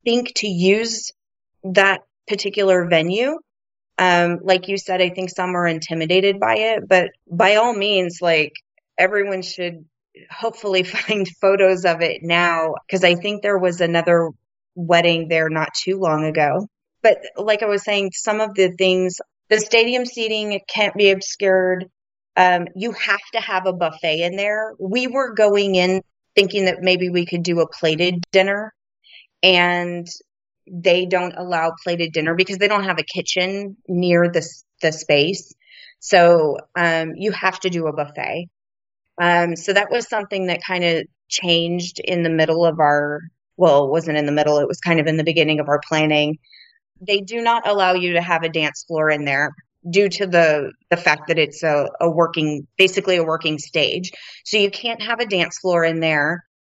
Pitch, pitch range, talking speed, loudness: 180 Hz, 165-200 Hz, 180 wpm, -18 LUFS